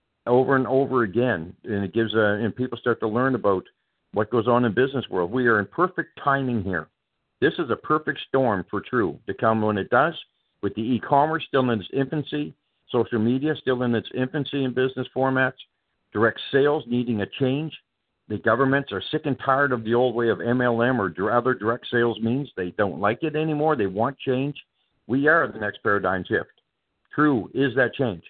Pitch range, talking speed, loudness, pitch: 110-135 Hz, 200 wpm, -23 LUFS, 125 Hz